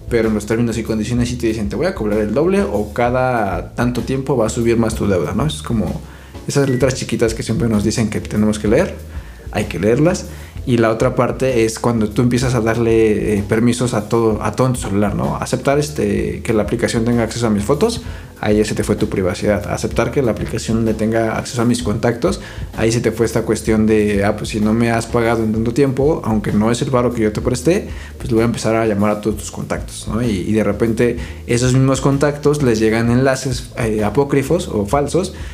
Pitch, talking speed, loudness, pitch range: 115 Hz, 235 wpm, -17 LUFS, 105-120 Hz